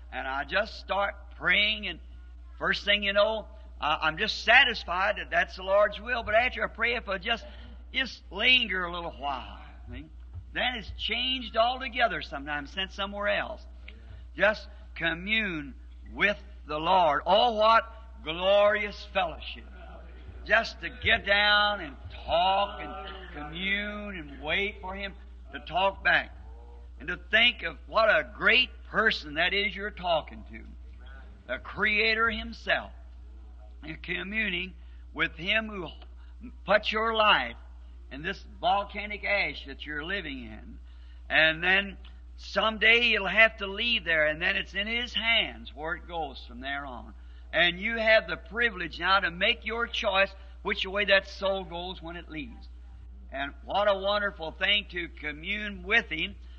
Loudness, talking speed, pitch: -26 LUFS, 150 wpm, 185 Hz